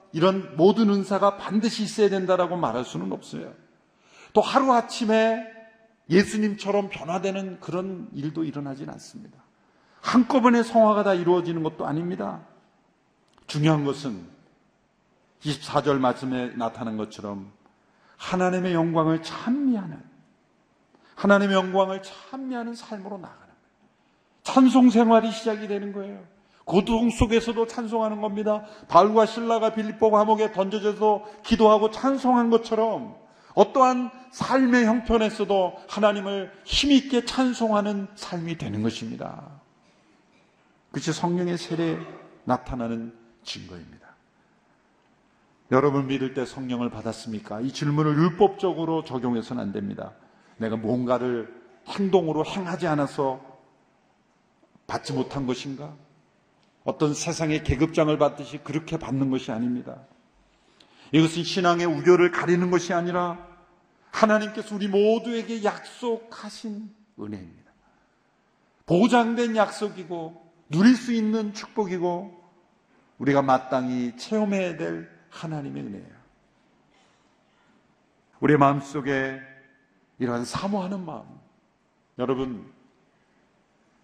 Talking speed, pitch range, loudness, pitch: 270 characters per minute, 145-215 Hz, -24 LUFS, 185 Hz